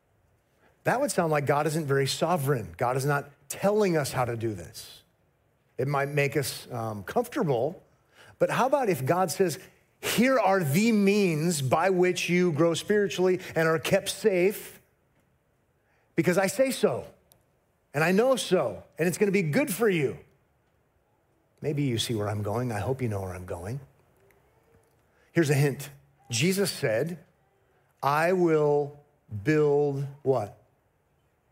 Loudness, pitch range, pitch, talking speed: -26 LUFS, 135-185 Hz, 150 Hz, 150 wpm